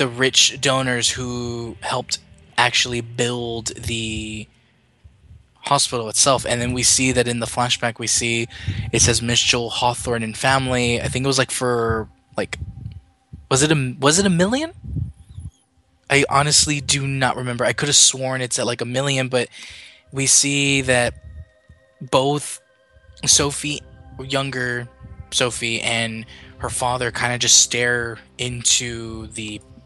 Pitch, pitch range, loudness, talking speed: 120 Hz, 115-130 Hz, -18 LUFS, 145 wpm